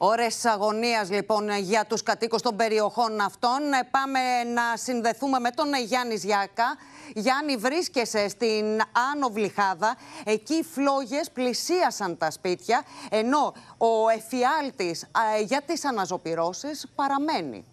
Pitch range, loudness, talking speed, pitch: 215-275 Hz, -26 LUFS, 115 wpm, 235 Hz